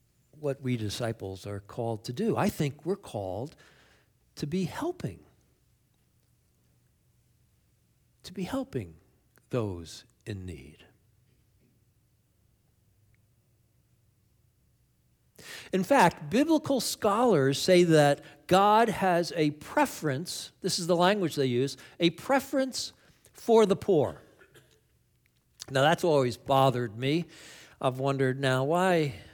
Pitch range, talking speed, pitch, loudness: 115-180 Hz, 100 wpm, 135 Hz, -27 LUFS